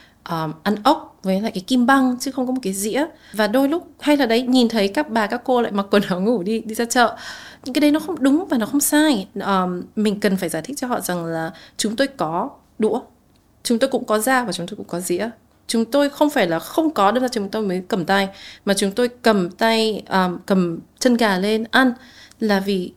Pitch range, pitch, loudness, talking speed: 195-265 Hz, 225 Hz, -20 LUFS, 255 wpm